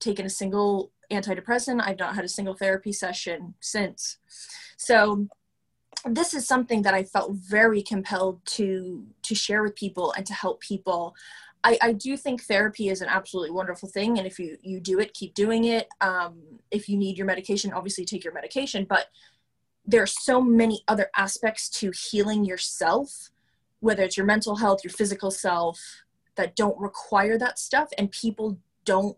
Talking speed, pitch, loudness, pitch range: 175 wpm, 200 Hz, -25 LUFS, 190-220 Hz